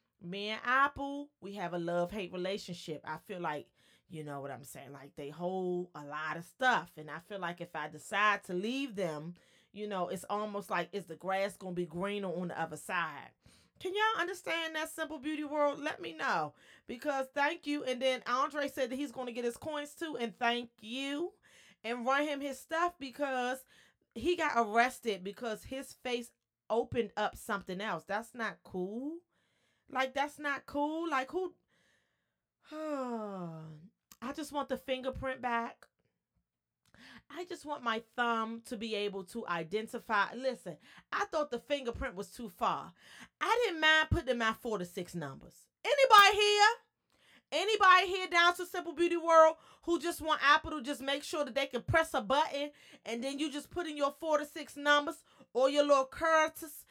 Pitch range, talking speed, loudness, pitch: 200-300 Hz, 185 wpm, -33 LUFS, 255 Hz